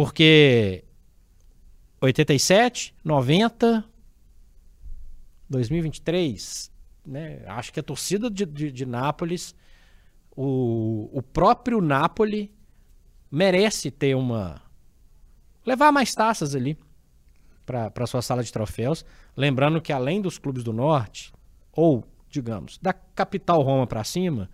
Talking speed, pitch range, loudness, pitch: 110 wpm, 100-165 Hz, -23 LUFS, 135 Hz